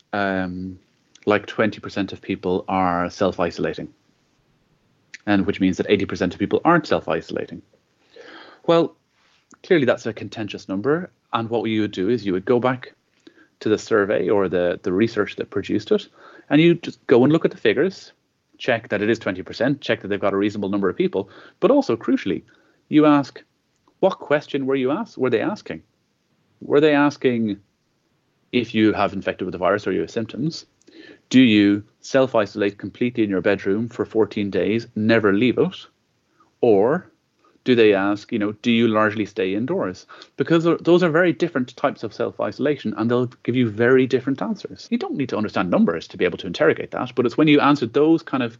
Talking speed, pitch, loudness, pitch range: 190 wpm, 110 Hz, -21 LUFS, 100-135 Hz